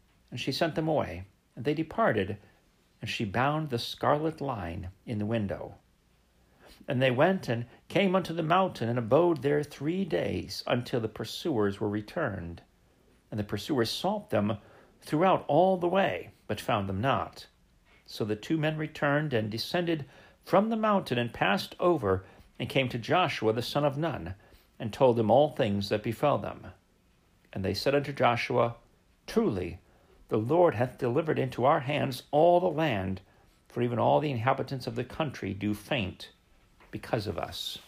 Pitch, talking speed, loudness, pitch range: 120 Hz, 170 wpm, -29 LUFS, 105-150 Hz